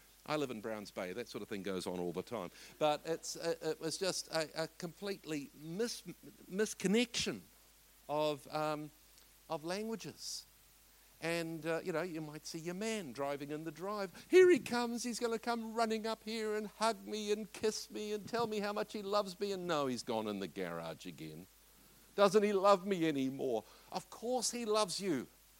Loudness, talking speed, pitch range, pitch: -37 LUFS, 195 wpm, 150-215 Hz, 180 Hz